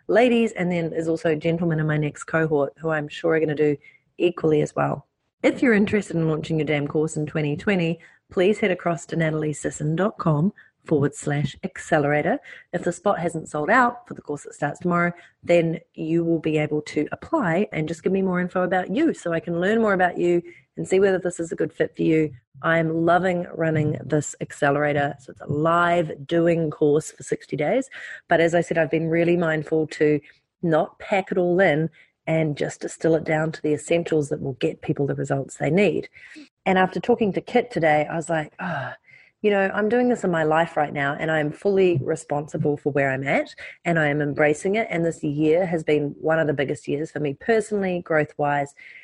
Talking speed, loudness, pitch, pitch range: 215 wpm, -23 LUFS, 165 Hz, 150-180 Hz